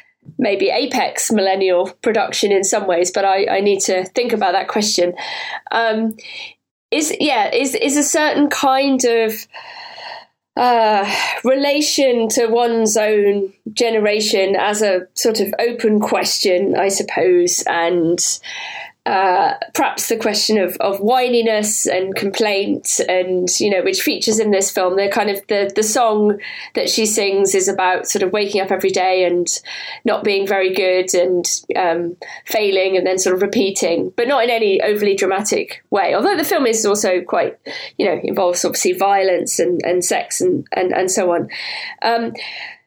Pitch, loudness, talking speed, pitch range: 205 Hz, -16 LUFS, 160 wpm, 190-230 Hz